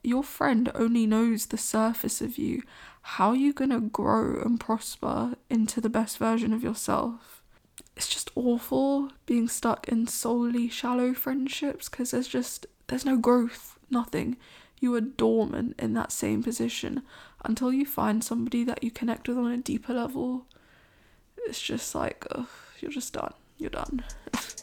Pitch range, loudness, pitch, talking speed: 230-265 Hz, -28 LUFS, 245 Hz, 160 wpm